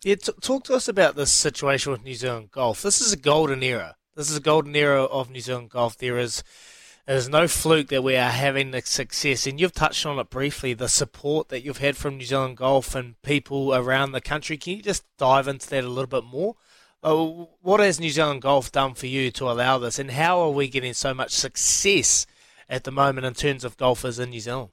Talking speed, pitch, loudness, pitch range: 240 wpm, 135 Hz, -23 LUFS, 130-150 Hz